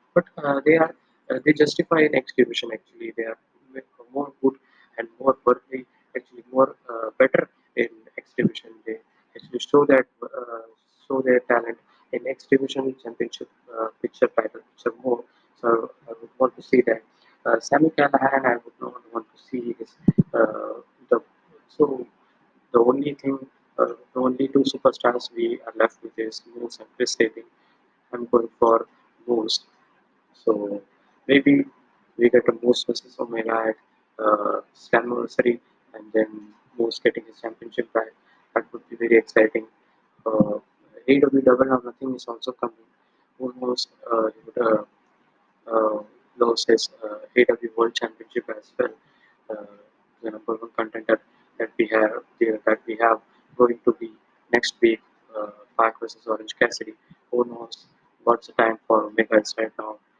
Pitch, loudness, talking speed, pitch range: 120 Hz, -23 LUFS, 155 wpm, 115-135 Hz